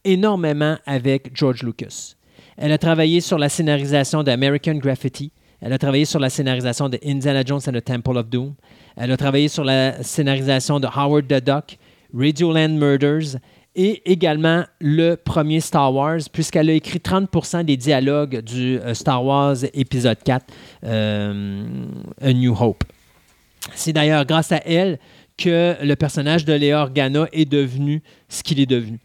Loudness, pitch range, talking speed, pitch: -19 LUFS, 130-155 Hz, 160 wpm, 145 Hz